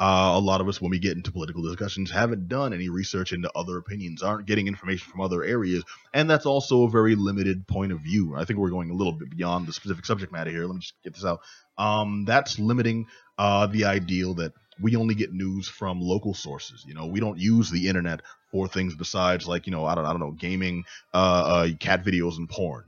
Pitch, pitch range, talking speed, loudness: 95 Hz, 90-105 Hz, 240 wpm, -26 LUFS